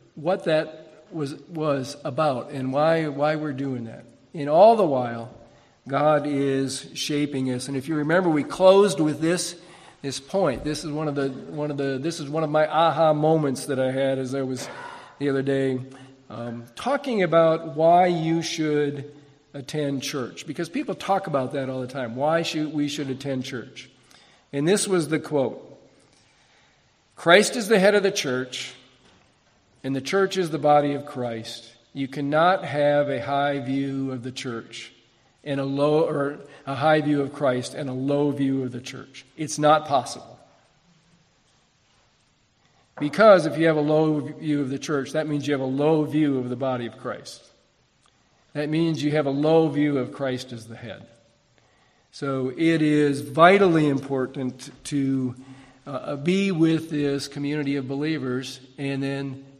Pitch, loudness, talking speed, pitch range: 145 Hz, -23 LUFS, 175 wpm, 135-155 Hz